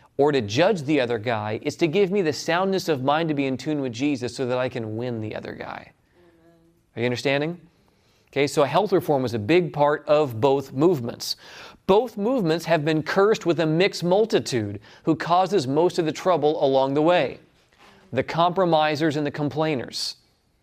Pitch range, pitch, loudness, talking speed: 135-170 Hz, 155 Hz, -23 LUFS, 190 wpm